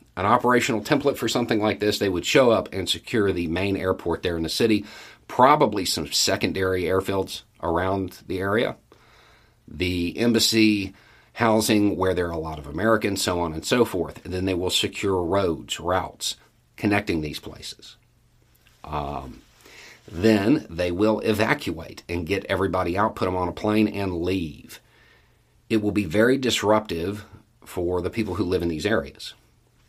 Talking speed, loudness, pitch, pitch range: 165 wpm, -23 LUFS, 100 Hz, 90-110 Hz